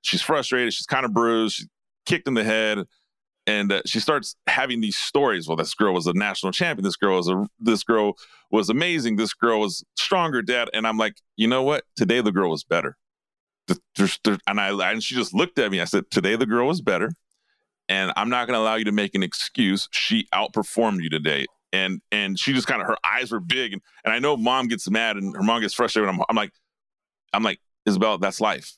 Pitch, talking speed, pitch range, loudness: 110 Hz, 230 wpm, 100-115 Hz, -23 LUFS